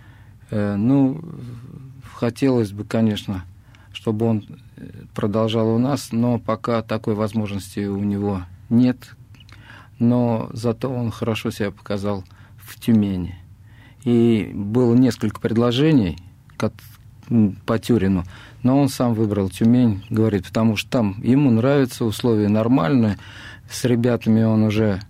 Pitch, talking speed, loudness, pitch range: 110 Hz, 110 wpm, -20 LUFS, 105-120 Hz